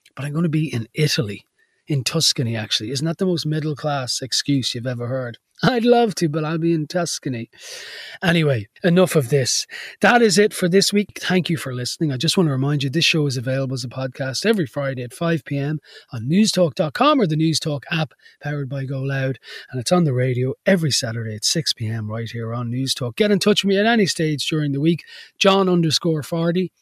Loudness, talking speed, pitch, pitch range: -20 LUFS, 215 wpm, 150 Hz, 130-175 Hz